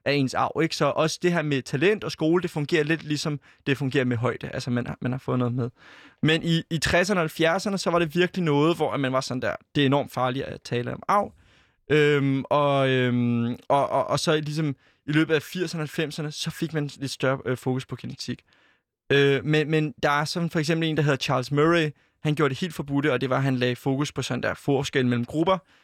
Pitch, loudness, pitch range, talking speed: 145 Hz, -25 LUFS, 135-160 Hz, 245 wpm